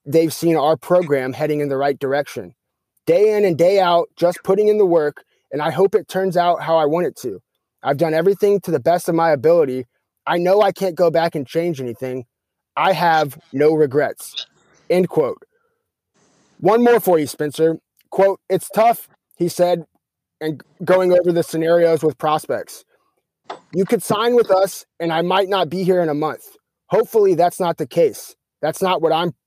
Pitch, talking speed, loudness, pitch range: 175 Hz, 190 wpm, -18 LUFS, 155-195 Hz